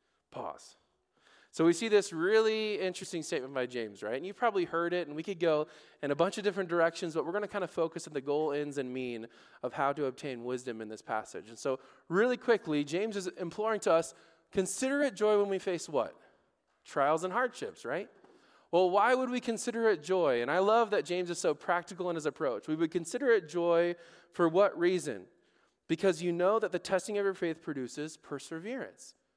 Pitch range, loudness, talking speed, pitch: 155-210 Hz, -32 LUFS, 215 wpm, 175 Hz